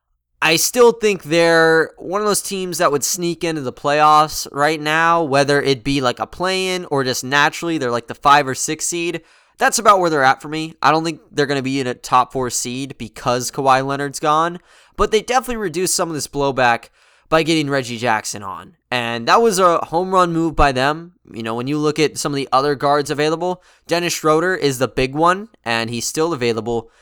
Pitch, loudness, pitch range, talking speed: 150 Hz, -17 LUFS, 130-170 Hz, 220 wpm